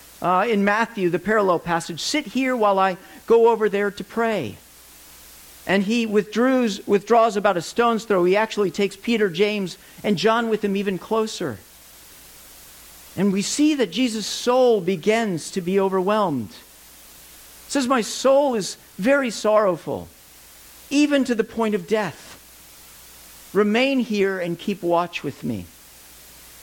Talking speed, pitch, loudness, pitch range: 140 wpm, 205 Hz, -21 LUFS, 165-225 Hz